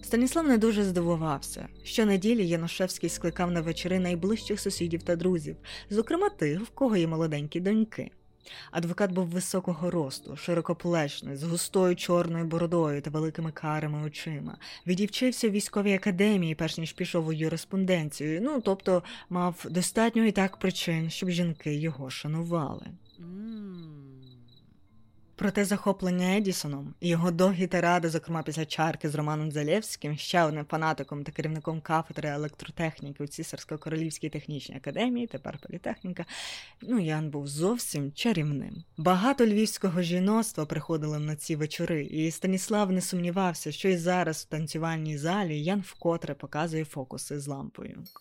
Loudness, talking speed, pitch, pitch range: -29 LUFS, 135 wpm, 170 Hz, 155-190 Hz